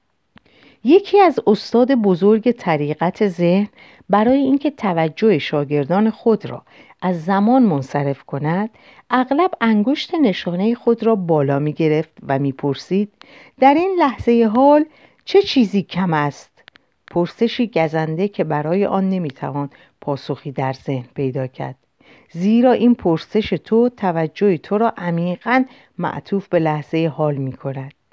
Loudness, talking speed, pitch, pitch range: -18 LUFS, 130 wpm, 195 Hz, 155-235 Hz